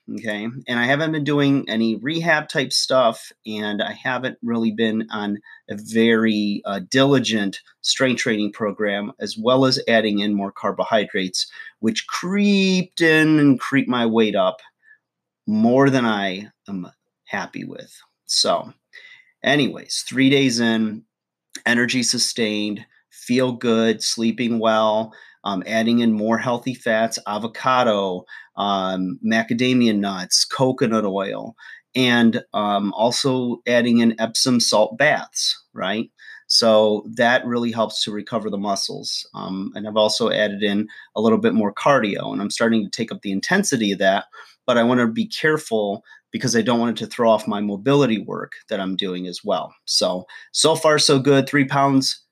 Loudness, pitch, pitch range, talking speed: -20 LUFS, 115 Hz, 105-135 Hz, 155 wpm